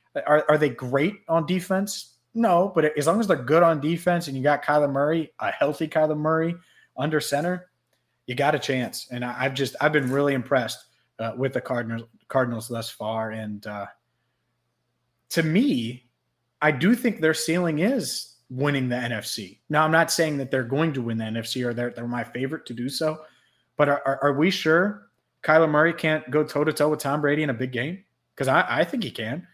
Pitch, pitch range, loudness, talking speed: 145 Hz, 125-160 Hz, -24 LUFS, 205 wpm